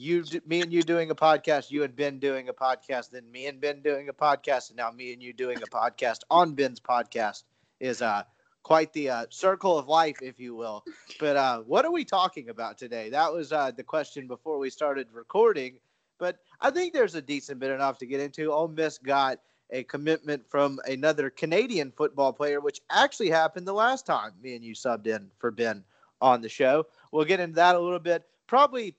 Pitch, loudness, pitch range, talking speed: 145 Hz, -27 LUFS, 130-170 Hz, 215 wpm